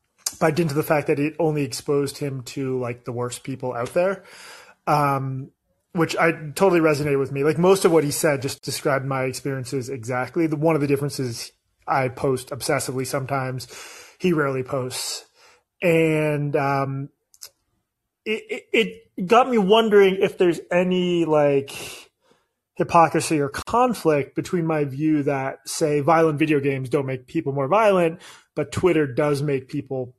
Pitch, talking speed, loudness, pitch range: 150 Hz, 160 wpm, -22 LUFS, 135-170 Hz